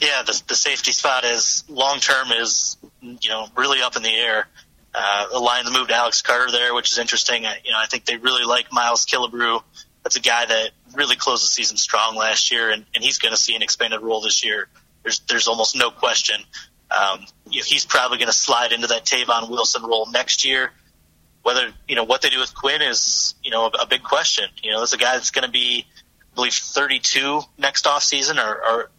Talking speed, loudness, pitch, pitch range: 225 wpm, -18 LUFS, 120 Hz, 110-125 Hz